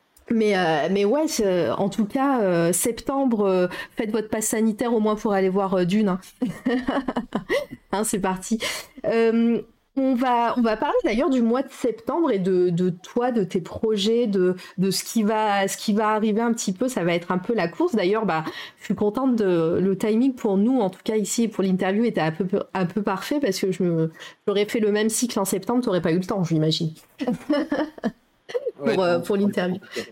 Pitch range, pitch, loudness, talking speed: 190-240 Hz, 215 Hz, -23 LUFS, 210 wpm